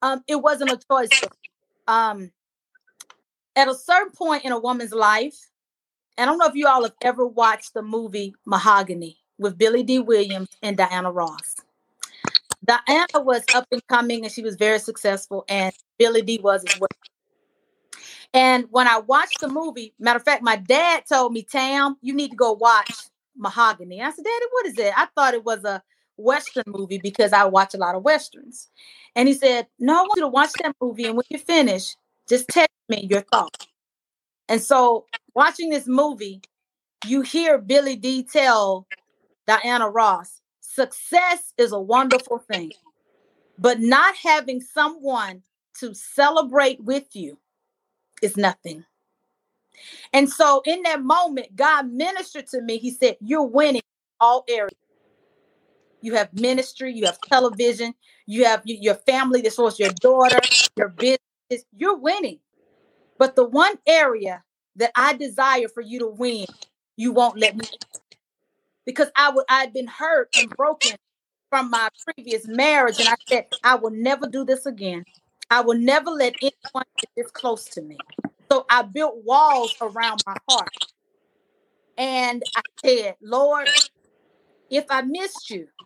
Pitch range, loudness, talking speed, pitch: 225-285 Hz, -20 LUFS, 165 wpm, 250 Hz